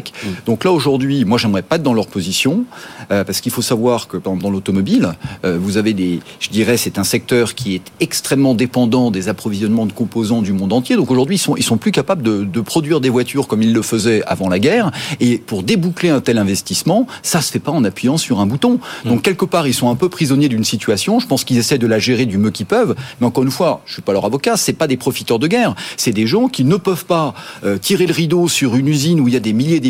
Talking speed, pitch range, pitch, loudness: 265 wpm, 110-165 Hz, 125 Hz, -15 LUFS